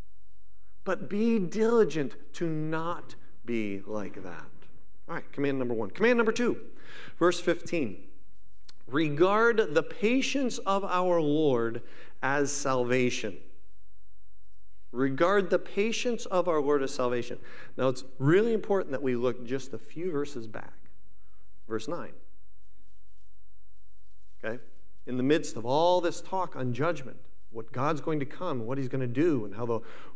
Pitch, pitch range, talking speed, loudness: 130 Hz, 100-170 Hz, 140 wpm, -29 LUFS